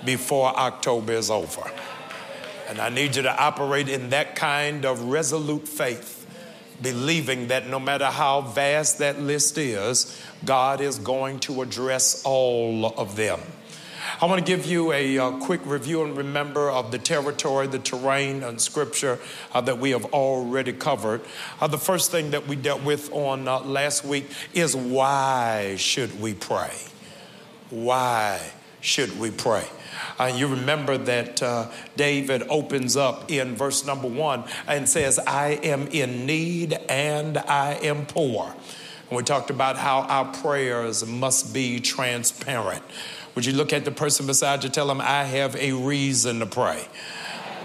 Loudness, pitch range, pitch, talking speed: -24 LUFS, 130-145 Hz, 135 Hz, 160 wpm